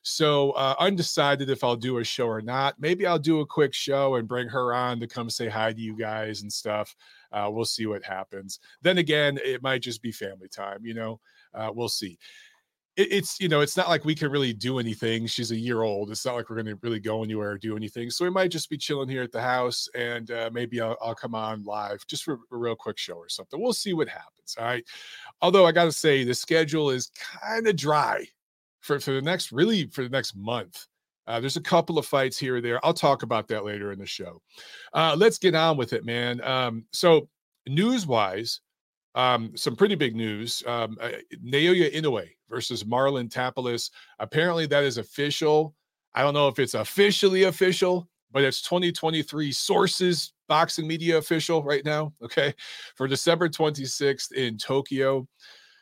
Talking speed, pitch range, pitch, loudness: 205 wpm, 115-160 Hz, 135 Hz, -26 LUFS